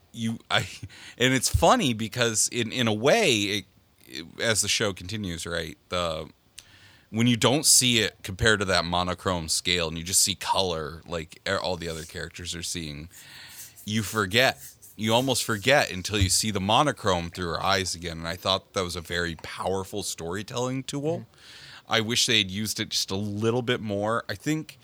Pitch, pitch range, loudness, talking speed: 105 Hz, 90-115 Hz, -25 LUFS, 185 wpm